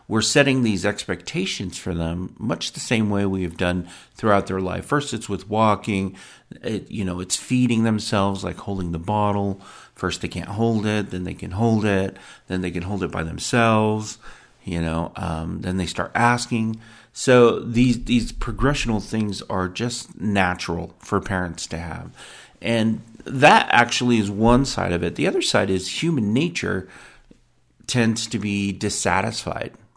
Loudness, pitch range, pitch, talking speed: -22 LUFS, 90-115 Hz, 105 Hz, 170 wpm